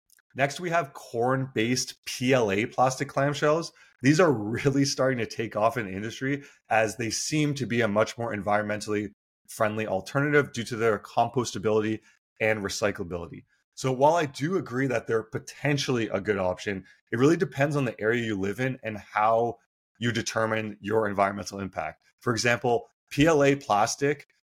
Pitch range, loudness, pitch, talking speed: 110-140 Hz, -27 LUFS, 120 Hz, 160 wpm